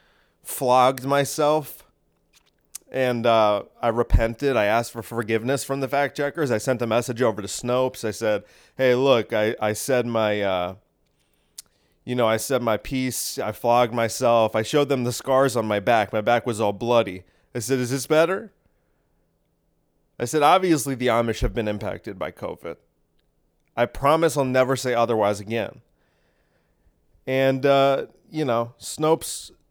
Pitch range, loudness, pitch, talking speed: 110-135 Hz, -22 LUFS, 120 Hz, 160 wpm